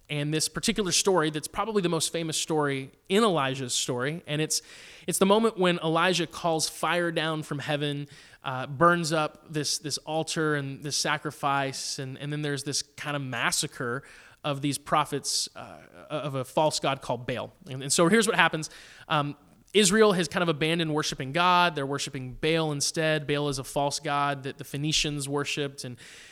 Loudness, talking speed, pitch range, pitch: -27 LUFS, 180 wpm, 140-165 Hz, 150 Hz